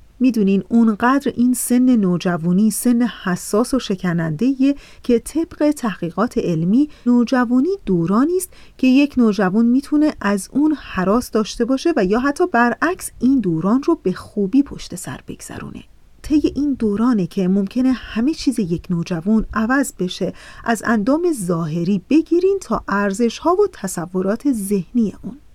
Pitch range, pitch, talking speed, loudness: 195-270 Hz, 235 Hz, 140 wpm, -18 LUFS